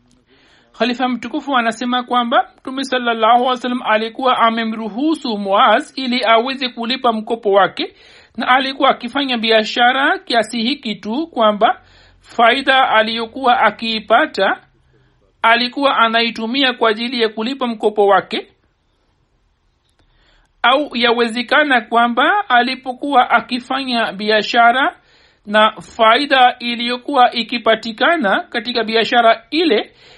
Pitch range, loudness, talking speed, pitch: 225-260 Hz, -15 LUFS, 95 wpm, 240 Hz